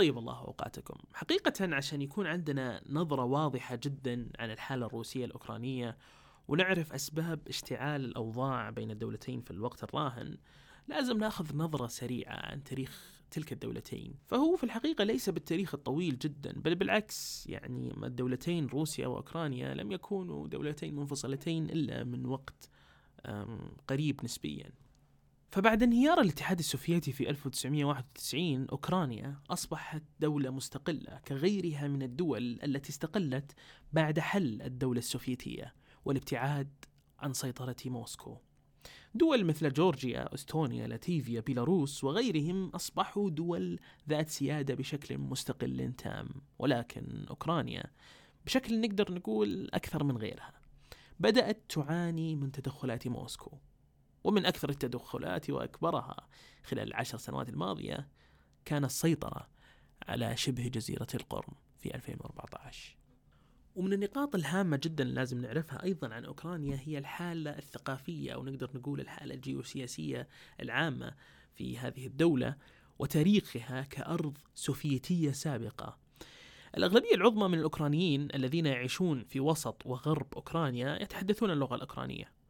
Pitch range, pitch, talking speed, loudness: 130-165 Hz, 140 Hz, 115 wpm, -35 LUFS